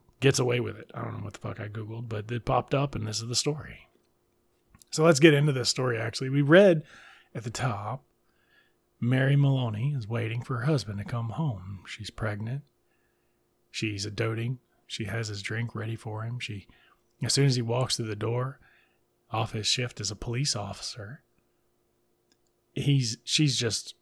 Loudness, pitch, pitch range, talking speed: -28 LUFS, 120 Hz, 110-130 Hz, 185 wpm